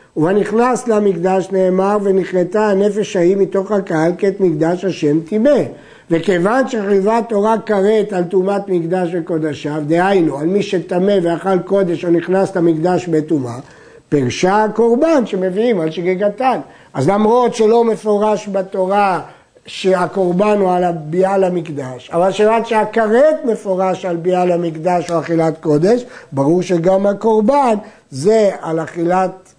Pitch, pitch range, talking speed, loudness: 190 Hz, 175-210 Hz, 125 wpm, -15 LUFS